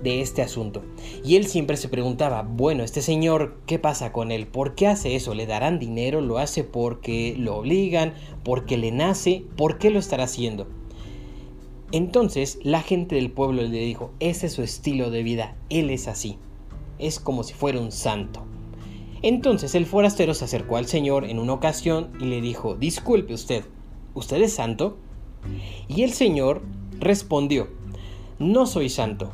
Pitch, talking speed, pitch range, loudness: 130 Hz, 170 wpm, 115-160 Hz, -24 LUFS